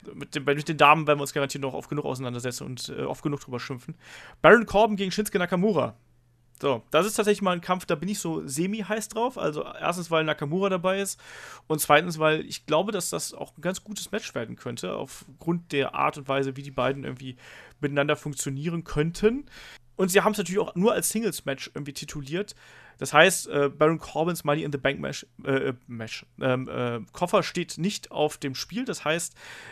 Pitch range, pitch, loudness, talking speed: 140-190 Hz, 155 Hz, -26 LUFS, 200 wpm